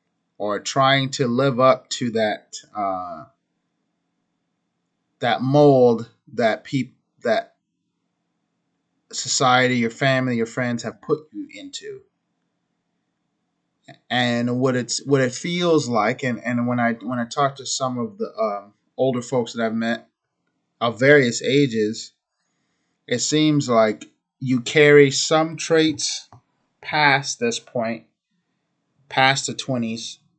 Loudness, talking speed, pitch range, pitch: -20 LUFS, 120 wpm, 115-145 Hz, 130 Hz